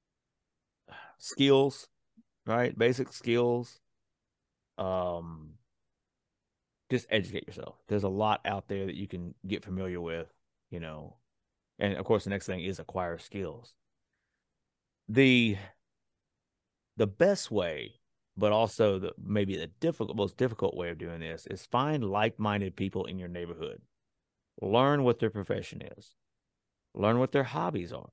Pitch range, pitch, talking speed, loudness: 90-120 Hz, 100 Hz, 135 wpm, -31 LUFS